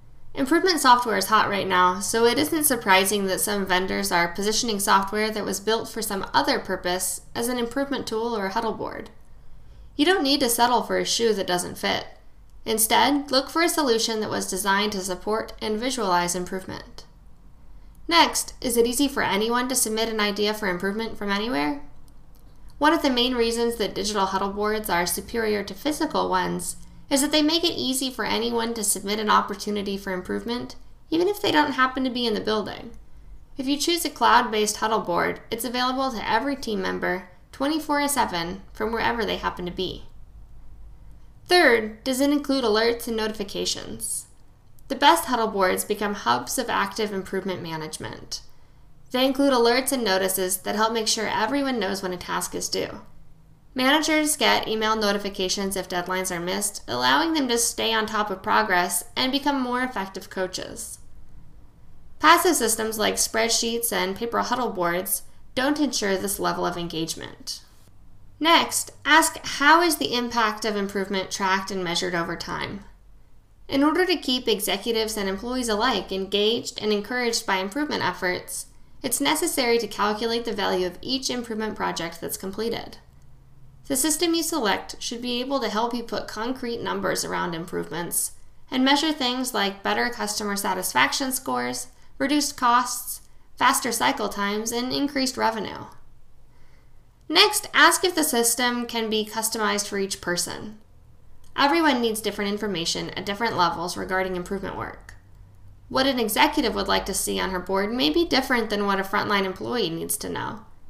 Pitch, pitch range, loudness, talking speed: 220 Hz, 190-255 Hz, -23 LUFS, 165 wpm